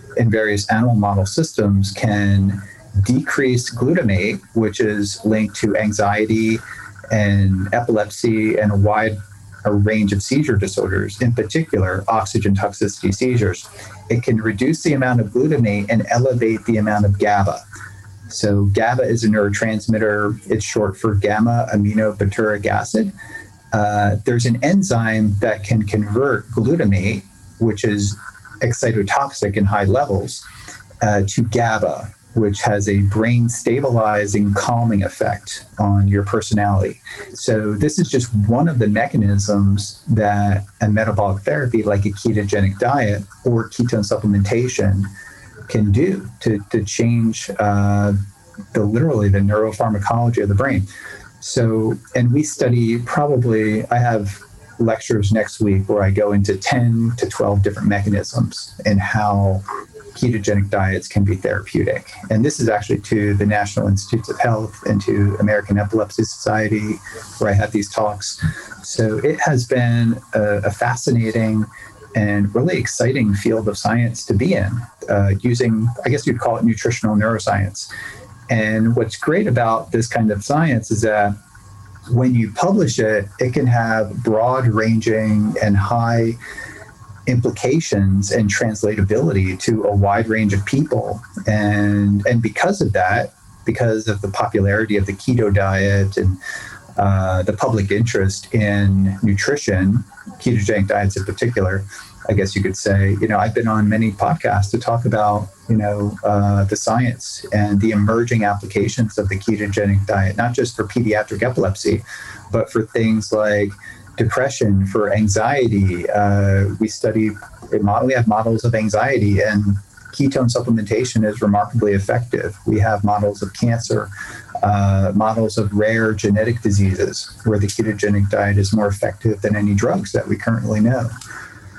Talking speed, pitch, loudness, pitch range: 145 wpm, 105 Hz, -18 LUFS, 100-115 Hz